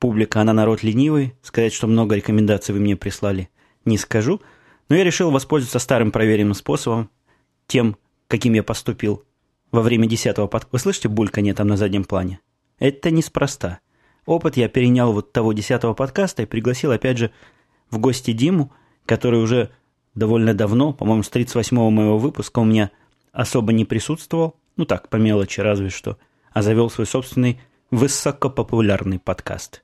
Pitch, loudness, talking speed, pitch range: 115 Hz, -19 LUFS, 155 wpm, 105-130 Hz